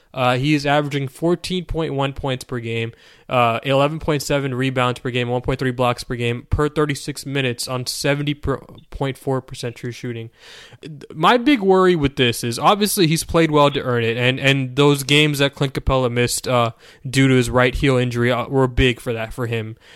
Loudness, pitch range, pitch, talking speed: -19 LUFS, 125-145 Hz, 135 Hz, 205 wpm